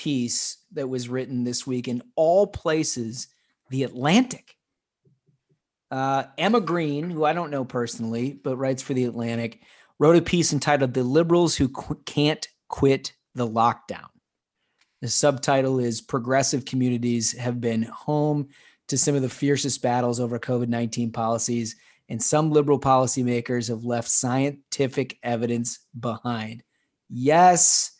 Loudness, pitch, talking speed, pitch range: -23 LUFS, 130 Hz, 135 wpm, 120-145 Hz